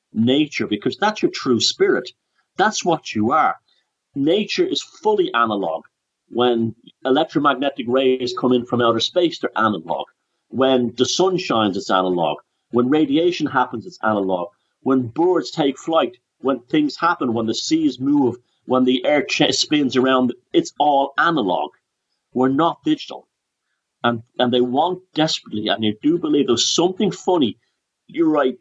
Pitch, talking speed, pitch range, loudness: 130 Hz, 150 wpm, 120-180 Hz, -19 LUFS